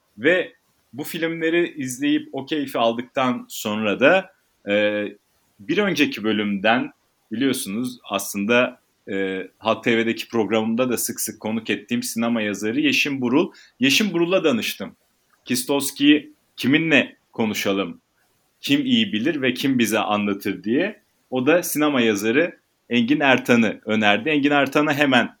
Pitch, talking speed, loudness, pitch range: 130 Hz, 120 wpm, -21 LUFS, 110-155 Hz